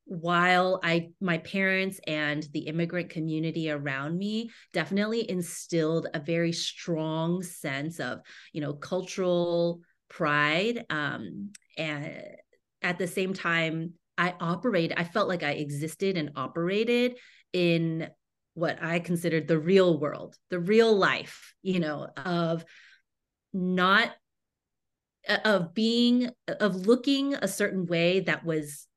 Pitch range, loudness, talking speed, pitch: 160-190 Hz, -28 LUFS, 120 wpm, 175 Hz